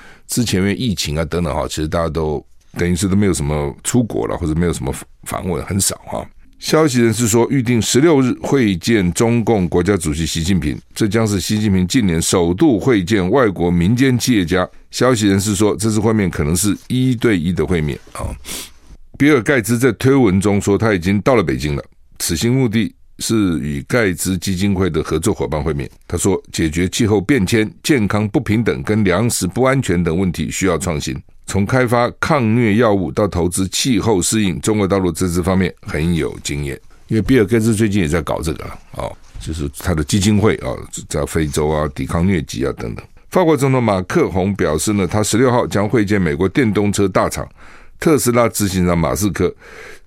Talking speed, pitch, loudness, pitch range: 300 characters per minute, 100 Hz, -16 LUFS, 85-115 Hz